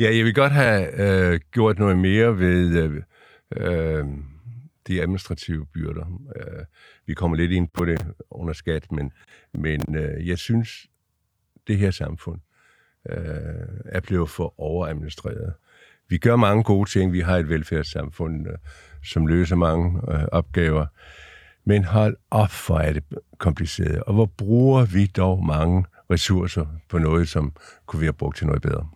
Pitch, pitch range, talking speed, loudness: 90 Hz, 80-100 Hz, 155 wpm, -22 LUFS